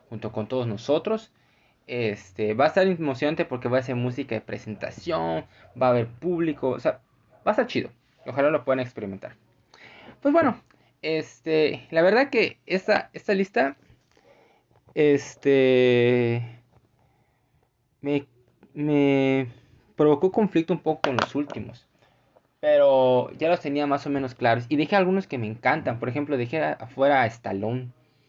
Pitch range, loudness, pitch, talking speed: 120-155 Hz, -24 LUFS, 135 Hz, 145 wpm